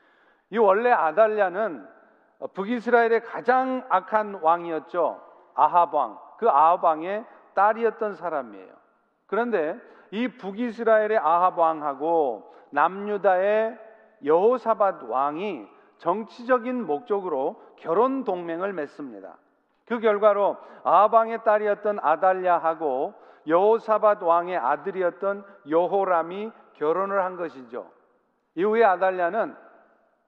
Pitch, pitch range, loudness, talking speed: 200 Hz, 170-220 Hz, -23 LUFS, 250 characters per minute